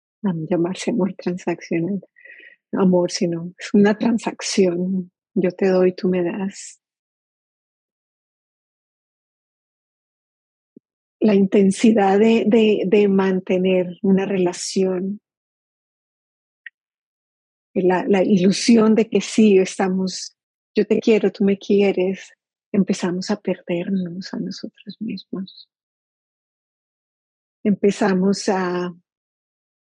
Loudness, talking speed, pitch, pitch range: -19 LUFS, 90 wpm, 195 Hz, 185-210 Hz